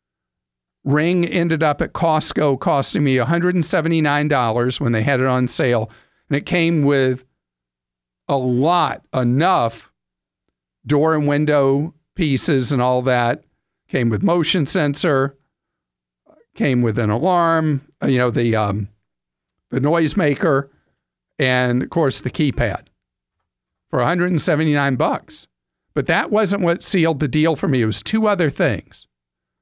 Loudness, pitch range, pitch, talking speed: -18 LUFS, 110-160 Hz, 135 Hz, 130 wpm